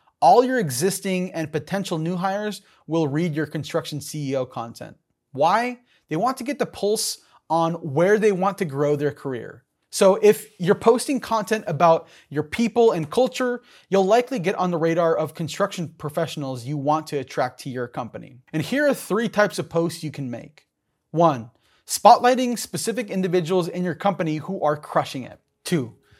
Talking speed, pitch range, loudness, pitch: 175 wpm, 150-210 Hz, -22 LUFS, 175 Hz